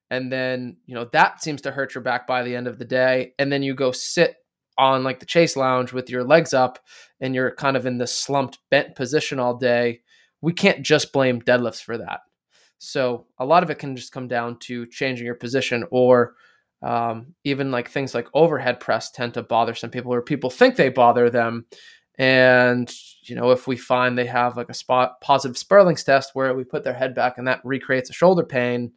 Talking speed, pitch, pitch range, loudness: 220 wpm, 130 Hz, 120-135 Hz, -21 LUFS